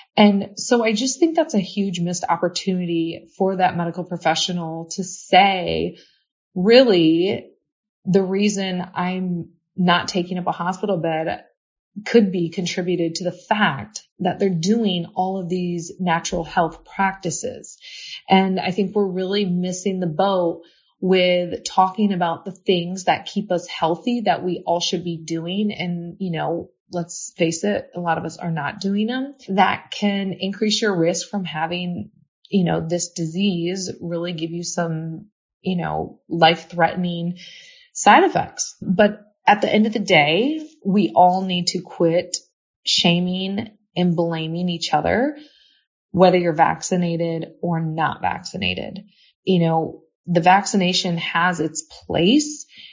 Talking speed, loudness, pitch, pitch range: 145 wpm, -20 LUFS, 180 Hz, 170-200 Hz